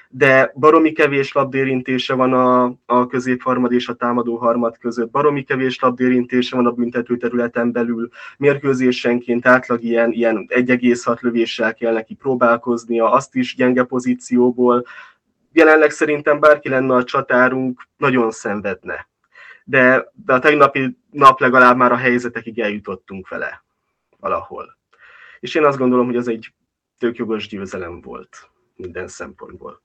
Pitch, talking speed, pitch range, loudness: 125 Hz, 135 wpm, 120-130 Hz, -16 LUFS